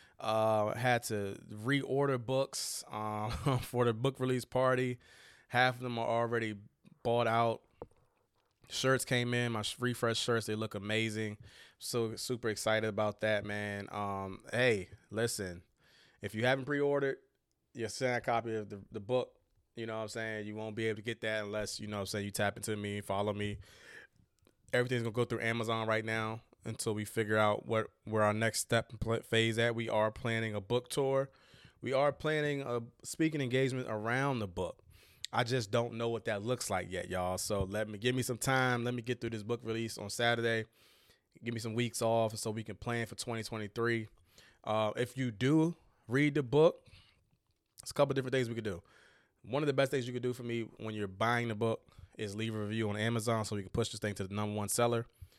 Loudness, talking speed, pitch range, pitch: -34 LUFS, 205 wpm, 105-125 Hz, 115 Hz